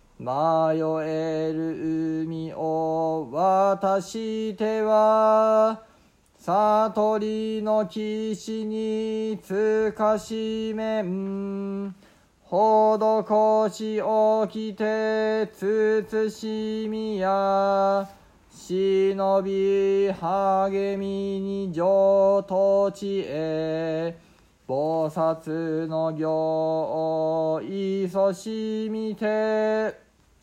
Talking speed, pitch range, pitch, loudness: 90 characters per minute, 175-215 Hz, 195 Hz, -24 LUFS